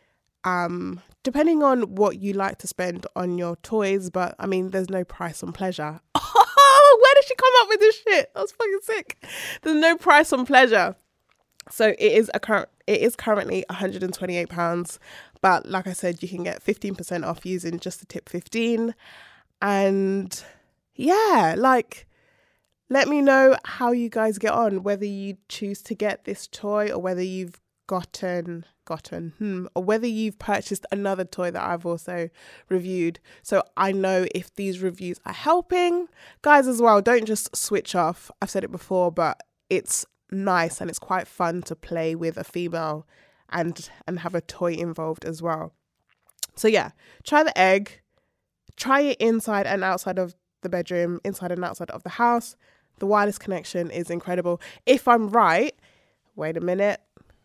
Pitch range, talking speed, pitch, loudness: 175-235 Hz, 170 wpm, 195 Hz, -22 LUFS